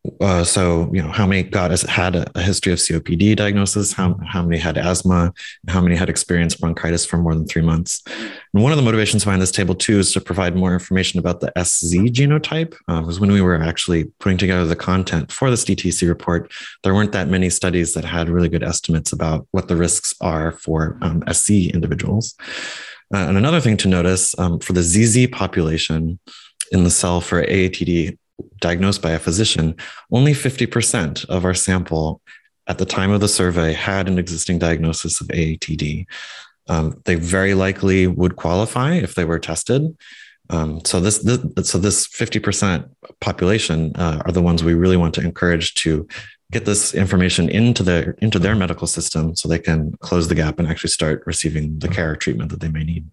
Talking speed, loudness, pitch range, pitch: 195 wpm, -18 LUFS, 85-100 Hz, 90 Hz